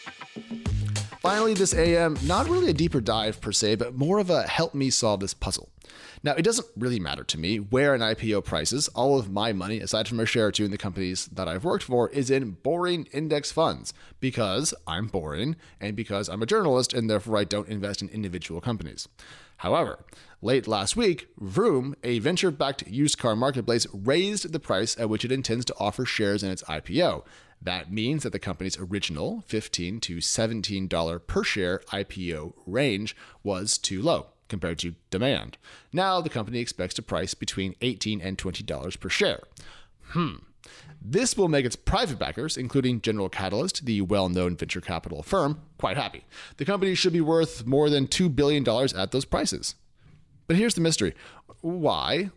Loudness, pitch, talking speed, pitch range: -26 LUFS, 115 Hz, 180 wpm, 100-145 Hz